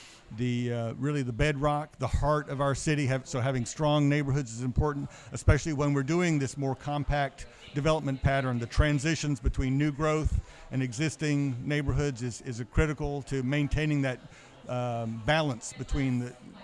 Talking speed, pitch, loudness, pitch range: 160 wpm, 140 Hz, -30 LUFS, 125-150 Hz